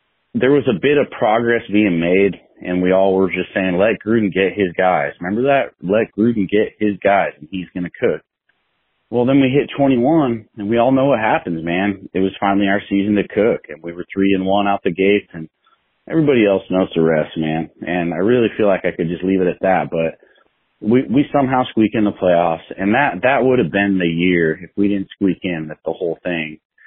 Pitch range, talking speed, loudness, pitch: 90-110 Hz, 230 wpm, -17 LUFS, 95 Hz